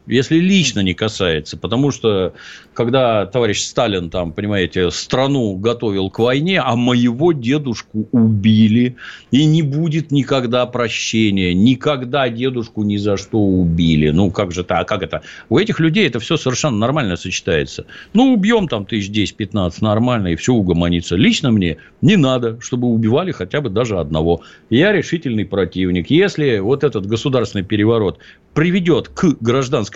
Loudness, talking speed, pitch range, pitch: -16 LUFS, 150 wpm, 100-140 Hz, 115 Hz